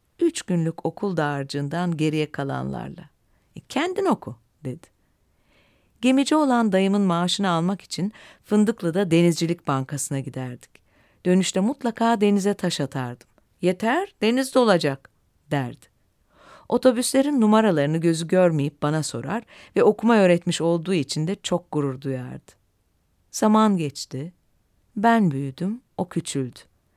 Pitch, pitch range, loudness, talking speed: 175 Hz, 140-210 Hz, -22 LUFS, 110 wpm